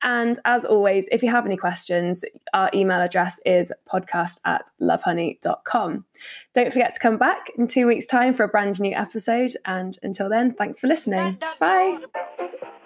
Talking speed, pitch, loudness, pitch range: 170 wpm, 225 Hz, -22 LUFS, 190-250 Hz